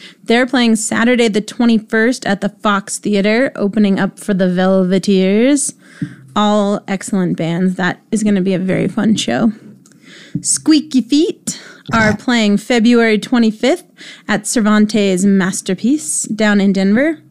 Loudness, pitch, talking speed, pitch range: -14 LUFS, 210 Hz, 130 wpm, 195-235 Hz